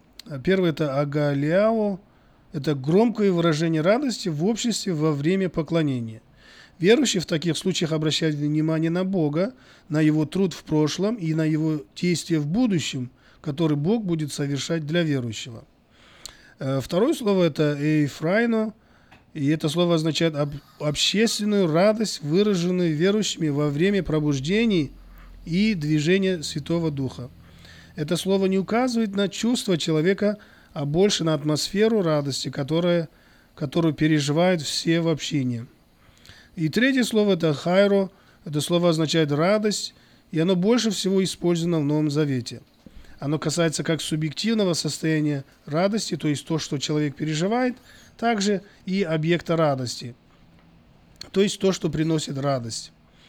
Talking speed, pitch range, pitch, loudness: 125 wpm, 150-190 Hz, 165 Hz, -23 LUFS